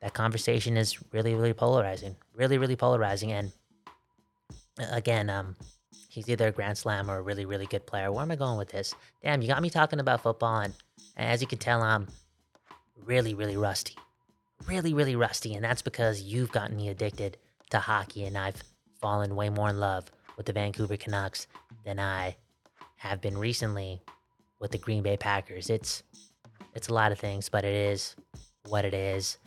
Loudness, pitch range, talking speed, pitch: -30 LUFS, 100-115 Hz, 185 wpm, 105 Hz